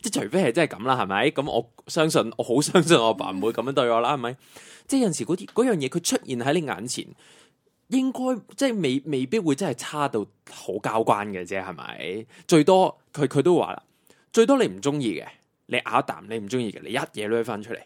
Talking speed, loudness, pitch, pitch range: 315 characters per minute, -24 LUFS, 145 Hz, 115-195 Hz